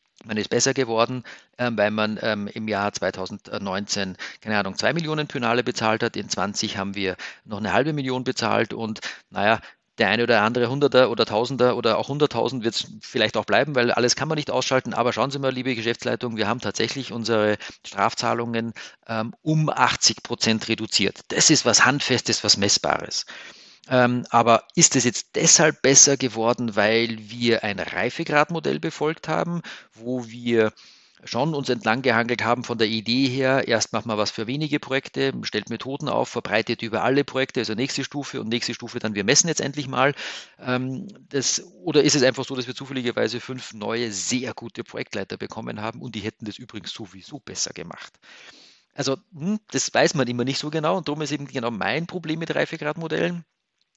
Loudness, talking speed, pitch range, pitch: -22 LUFS, 180 wpm, 115-135 Hz, 120 Hz